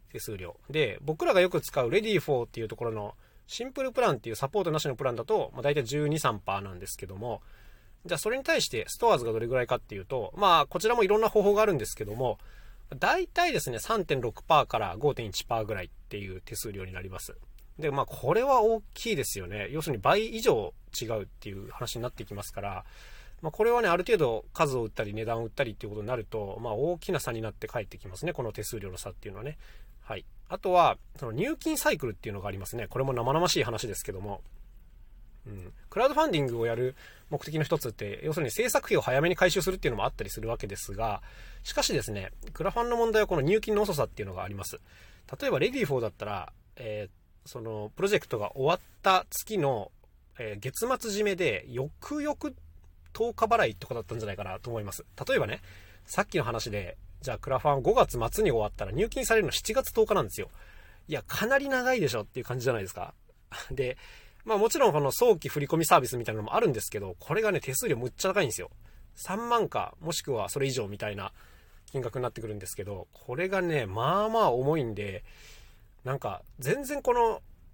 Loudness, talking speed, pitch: -29 LUFS, 440 characters per minute, 120 Hz